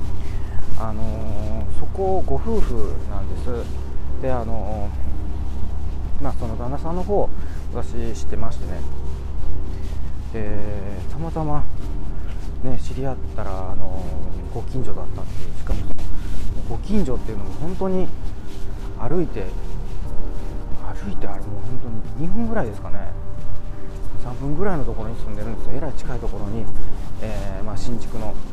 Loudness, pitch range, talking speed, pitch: -29 LUFS, 75-105 Hz, 280 characters per minute, 95 Hz